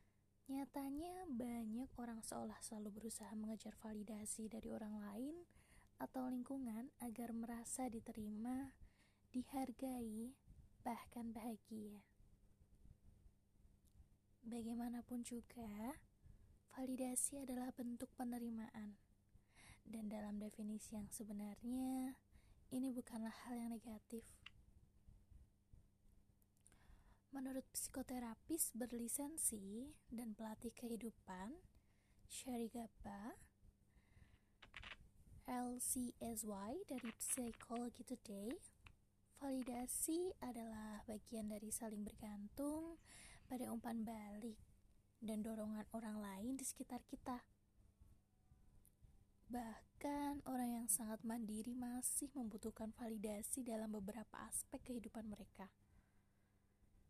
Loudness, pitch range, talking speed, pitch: -49 LUFS, 210-250 Hz, 80 wpm, 230 Hz